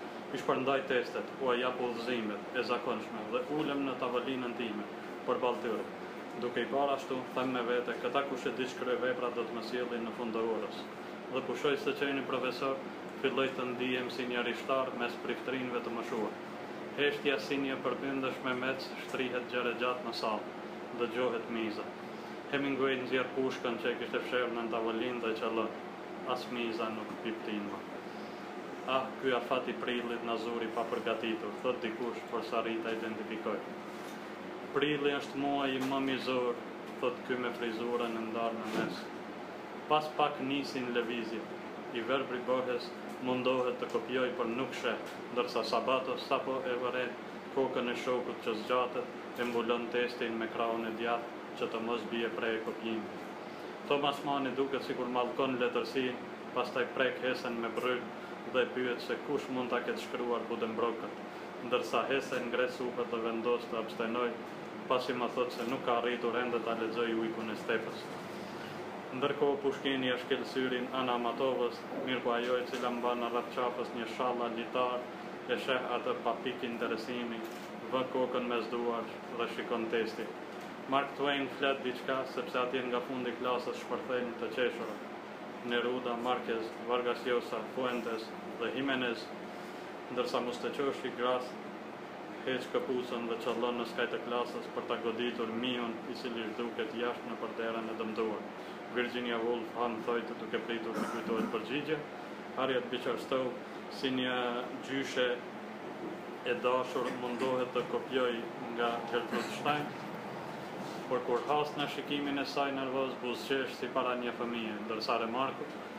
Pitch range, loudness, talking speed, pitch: 115-130 Hz, -35 LUFS, 155 wpm, 120 Hz